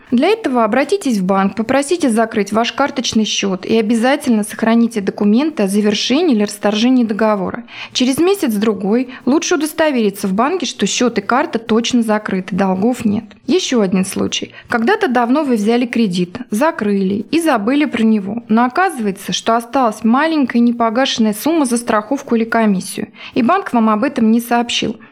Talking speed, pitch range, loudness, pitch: 155 wpm, 215-265 Hz, -15 LUFS, 230 Hz